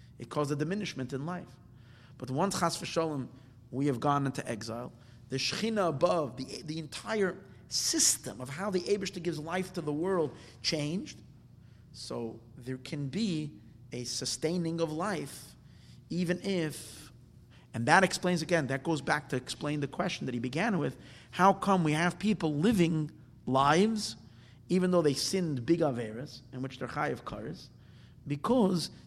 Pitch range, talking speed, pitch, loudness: 130-175 Hz, 160 wpm, 150 Hz, -31 LUFS